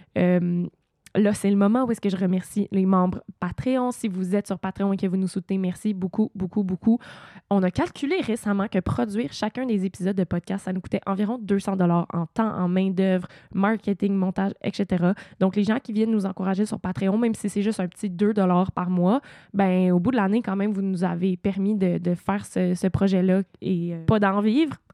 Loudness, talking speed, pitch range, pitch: -24 LUFS, 225 wpm, 185-210 Hz, 195 Hz